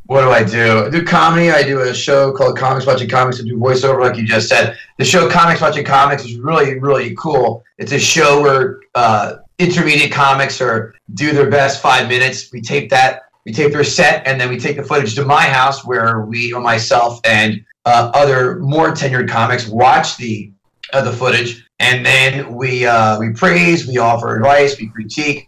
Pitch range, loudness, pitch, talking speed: 120-145 Hz, -12 LUFS, 130 Hz, 205 wpm